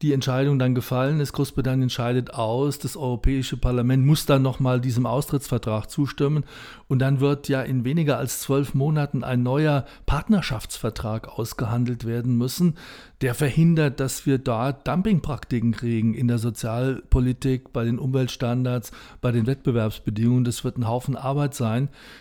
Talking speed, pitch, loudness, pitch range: 145 wpm, 130 Hz, -24 LUFS, 120-140 Hz